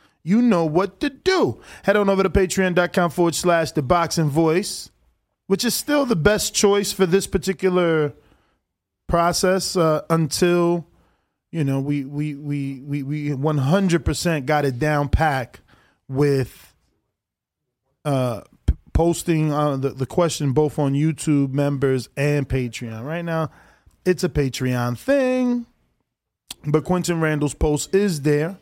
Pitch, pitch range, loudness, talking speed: 160 Hz, 145-185 Hz, -21 LUFS, 135 wpm